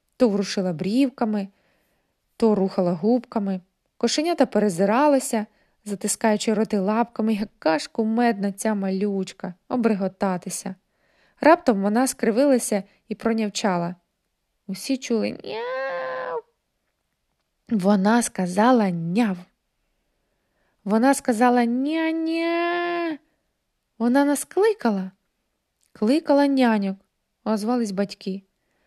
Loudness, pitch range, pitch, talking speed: -22 LUFS, 200-260 Hz, 220 Hz, 80 wpm